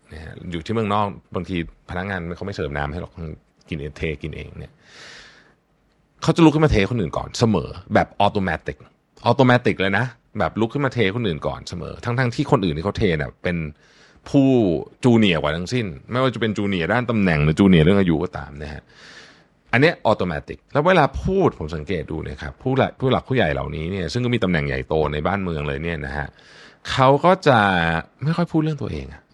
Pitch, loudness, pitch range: 95 Hz, -20 LUFS, 80-120 Hz